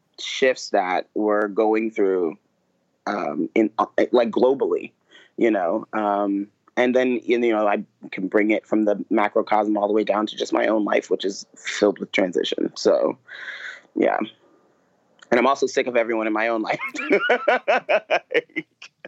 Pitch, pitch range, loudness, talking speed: 110 Hz, 105-115 Hz, -22 LUFS, 160 wpm